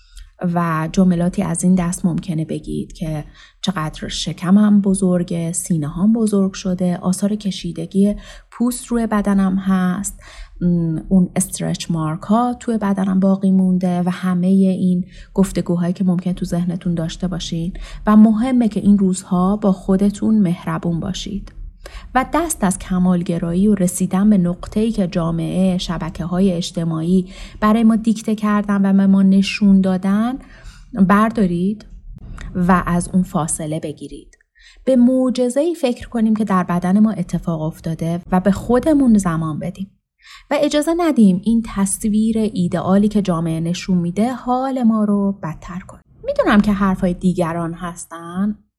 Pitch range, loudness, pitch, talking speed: 175-210 Hz, -17 LUFS, 190 Hz, 140 wpm